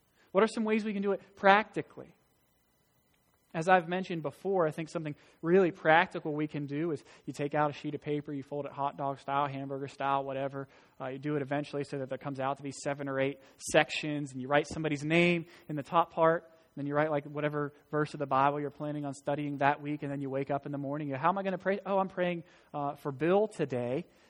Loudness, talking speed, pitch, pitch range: -32 LUFS, 250 wpm, 150 Hz, 140-165 Hz